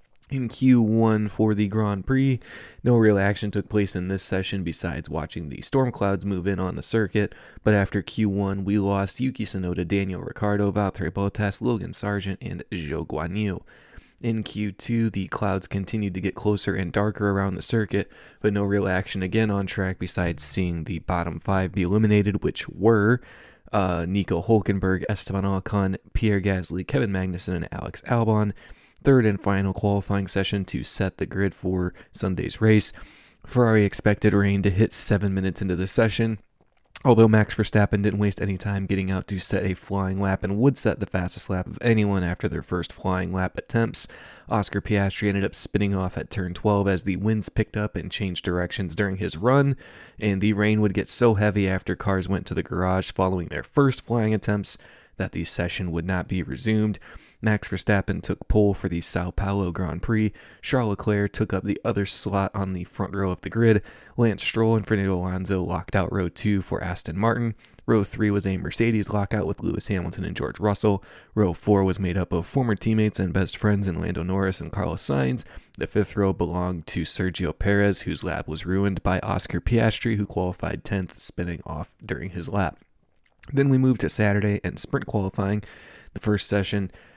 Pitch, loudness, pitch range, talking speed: 100 Hz, -24 LUFS, 95-105 Hz, 190 wpm